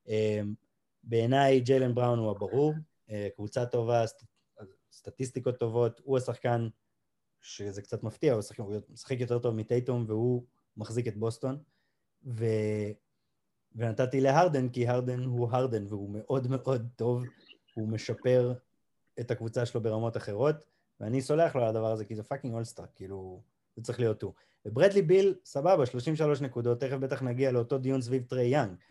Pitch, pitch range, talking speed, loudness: 120 Hz, 110-130 Hz, 150 wpm, -30 LUFS